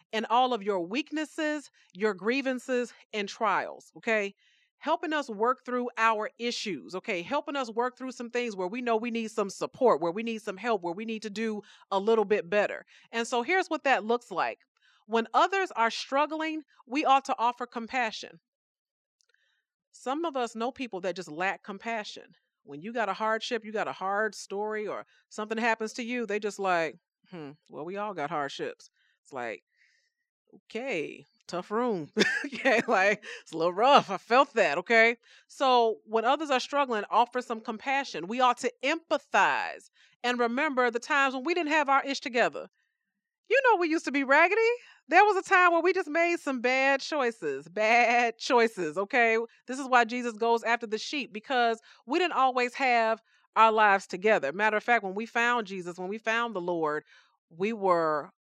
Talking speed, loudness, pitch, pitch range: 185 wpm, -28 LUFS, 235 Hz, 215-275 Hz